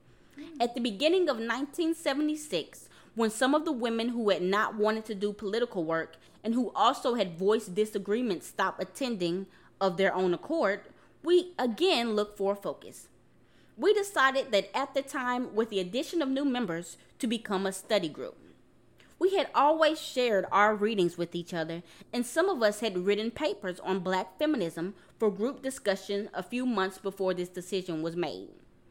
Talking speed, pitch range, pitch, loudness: 170 wpm, 190-270 Hz, 215 Hz, -30 LUFS